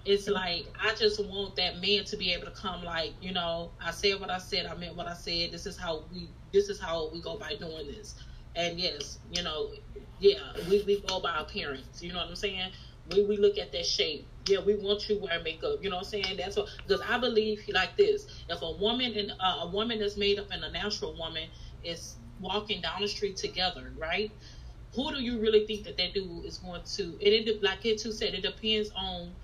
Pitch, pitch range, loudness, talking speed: 200 Hz, 175-215 Hz, -31 LUFS, 235 wpm